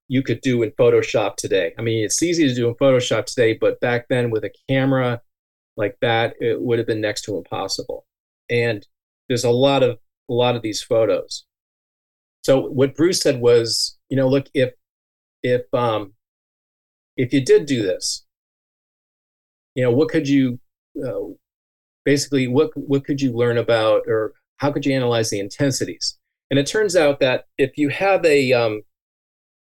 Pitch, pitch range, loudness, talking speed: 135 Hz, 120-155 Hz, -20 LUFS, 175 wpm